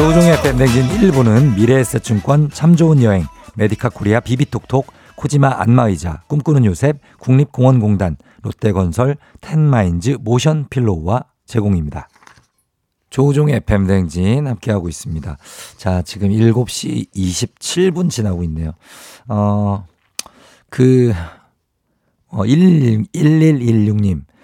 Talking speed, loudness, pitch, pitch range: 240 characters per minute, -15 LUFS, 120 Hz, 100-140 Hz